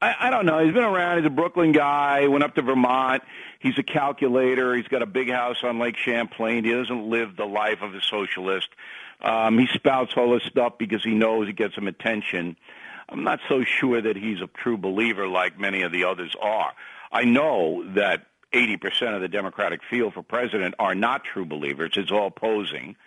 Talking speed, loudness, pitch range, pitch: 210 wpm, -23 LUFS, 105-130 Hz, 115 Hz